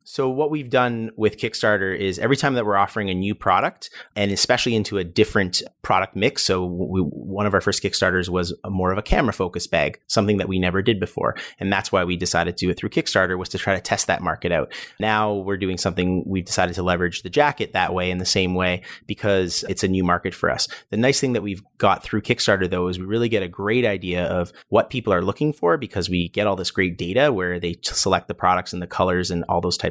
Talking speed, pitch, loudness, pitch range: 255 wpm, 95 Hz, -21 LUFS, 90-105 Hz